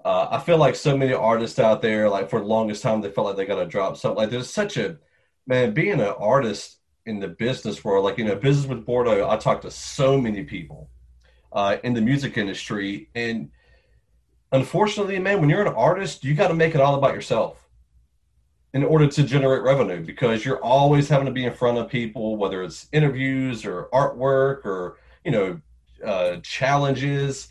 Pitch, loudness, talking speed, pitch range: 130 Hz, -22 LUFS, 200 wpm, 105-140 Hz